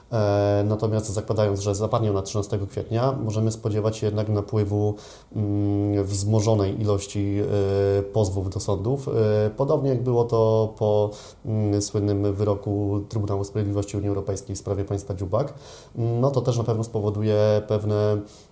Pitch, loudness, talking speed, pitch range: 105 Hz, -24 LUFS, 125 wpm, 100-110 Hz